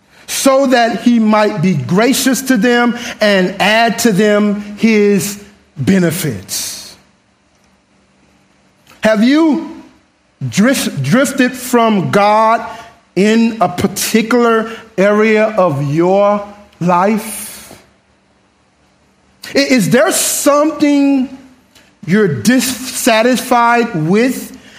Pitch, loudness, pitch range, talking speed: 225 Hz, -12 LUFS, 200-250 Hz, 75 wpm